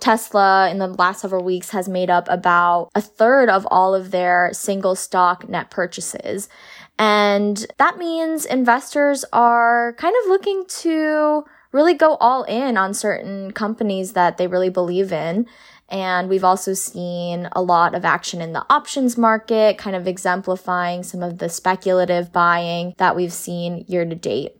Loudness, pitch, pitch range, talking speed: -18 LUFS, 190 Hz, 180-235 Hz, 165 wpm